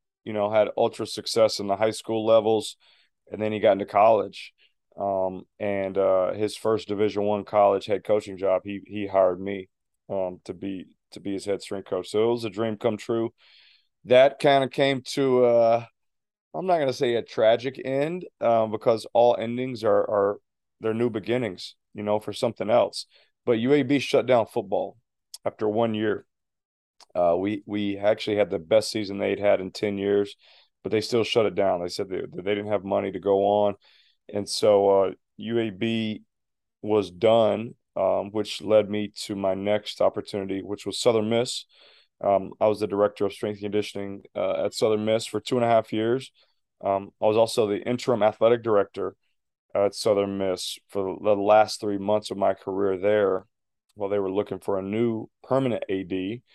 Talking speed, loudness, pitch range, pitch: 190 wpm, -25 LUFS, 100-115 Hz, 105 Hz